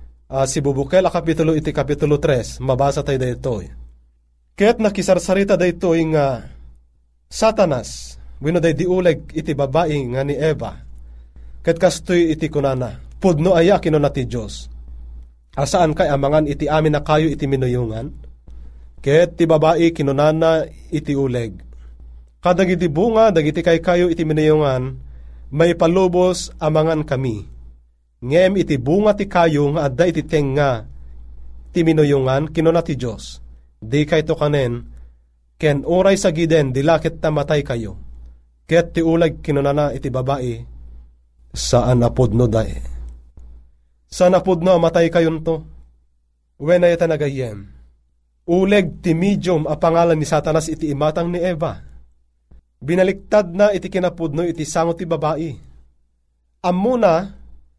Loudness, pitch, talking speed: -17 LUFS, 145 Hz, 125 wpm